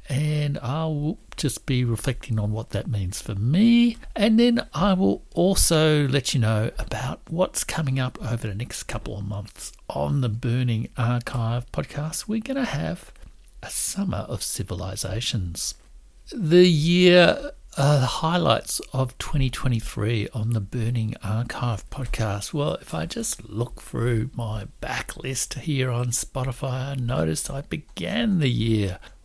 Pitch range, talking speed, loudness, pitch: 110-150 Hz, 150 wpm, -24 LUFS, 125 Hz